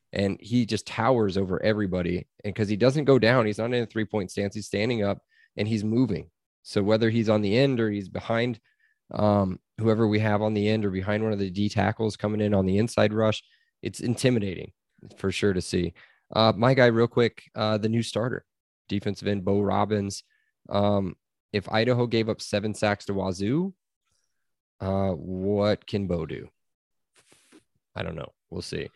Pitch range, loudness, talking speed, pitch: 100-115 Hz, -26 LUFS, 190 wpm, 105 Hz